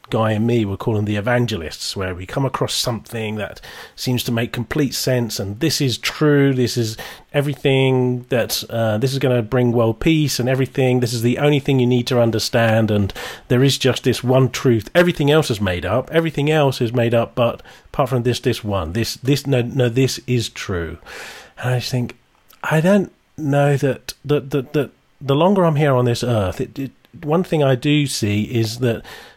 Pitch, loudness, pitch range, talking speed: 125 Hz, -19 LUFS, 115-140 Hz, 215 wpm